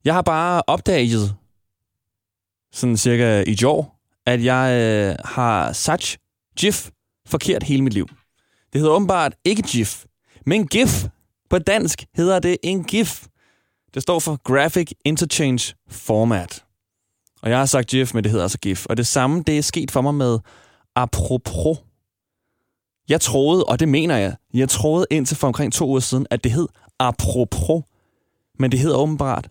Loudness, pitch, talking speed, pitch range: -19 LUFS, 125 Hz, 160 wpm, 105-145 Hz